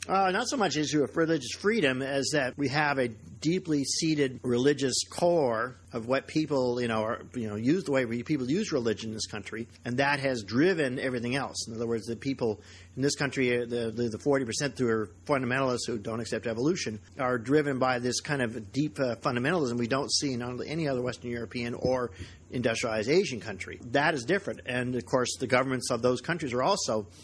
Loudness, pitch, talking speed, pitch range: -29 LUFS, 125 Hz, 205 wpm, 115-140 Hz